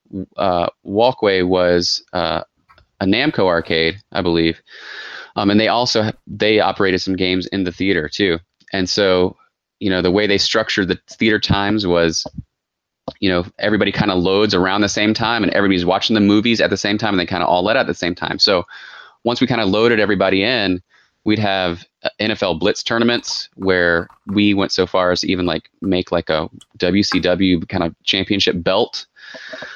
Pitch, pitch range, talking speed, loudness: 95 Hz, 90-105 Hz, 190 wpm, -17 LUFS